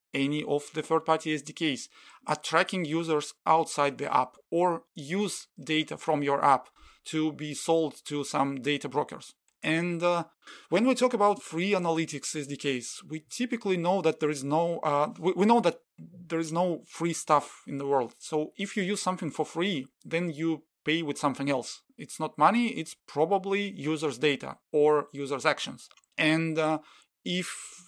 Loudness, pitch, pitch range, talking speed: -29 LUFS, 160 Hz, 150-175 Hz, 165 wpm